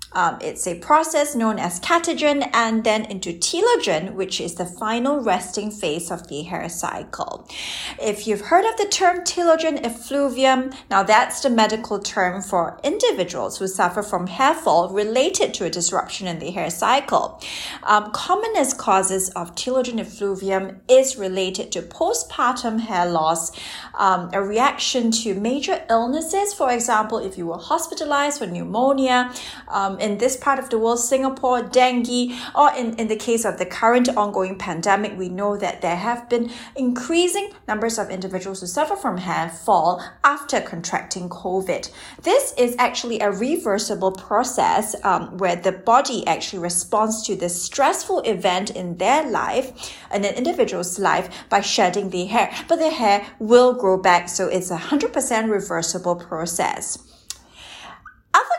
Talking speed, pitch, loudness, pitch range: 155 wpm, 220 Hz, -21 LUFS, 190-265 Hz